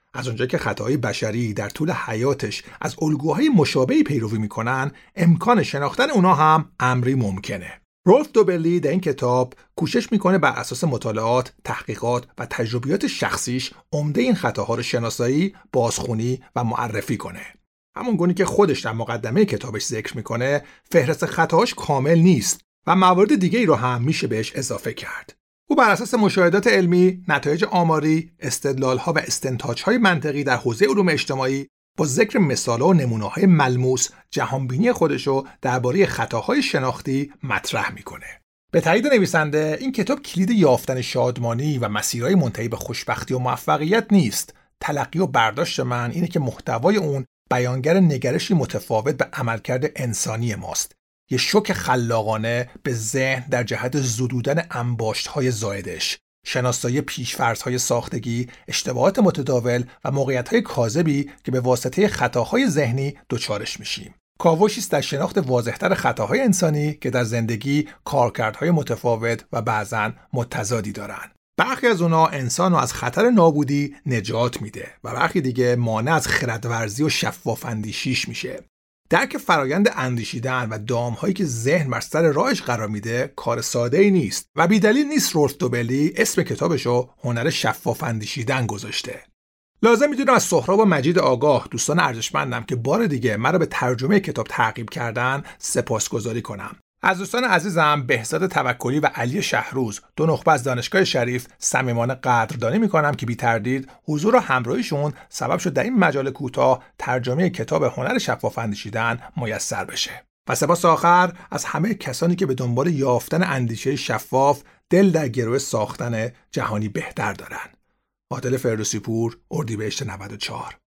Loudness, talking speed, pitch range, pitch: -21 LUFS, 145 wpm, 120-170 Hz, 135 Hz